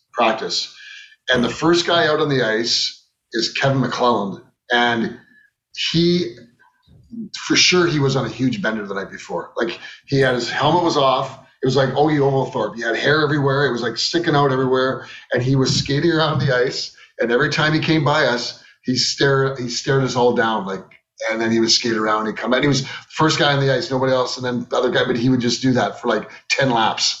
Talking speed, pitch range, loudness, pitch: 230 wpm, 120-150 Hz, -18 LUFS, 135 Hz